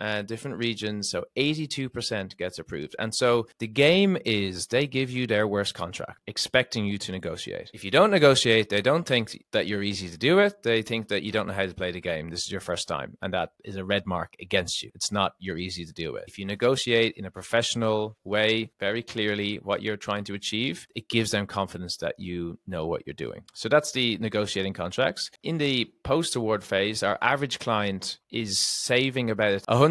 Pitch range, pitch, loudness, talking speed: 100-120 Hz, 110 Hz, -26 LUFS, 215 wpm